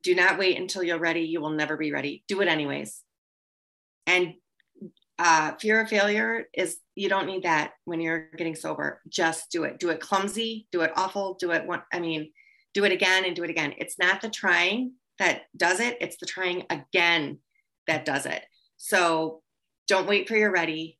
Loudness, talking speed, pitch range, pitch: -26 LUFS, 190 wpm, 165-195 Hz, 180 Hz